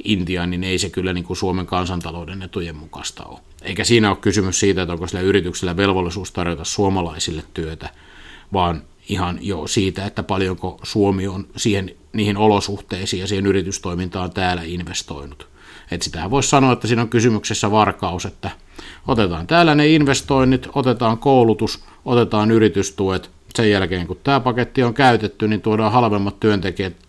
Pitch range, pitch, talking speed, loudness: 90-110 Hz, 95 Hz, 155 wpm, -19 LUFS